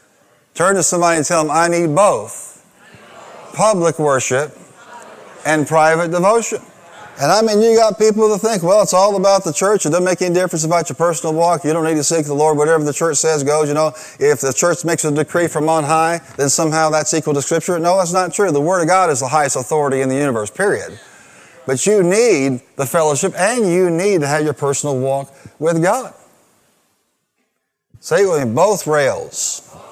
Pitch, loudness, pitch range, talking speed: 165 Hz, -15 LUFS, 150-185 Hz, 205 wpm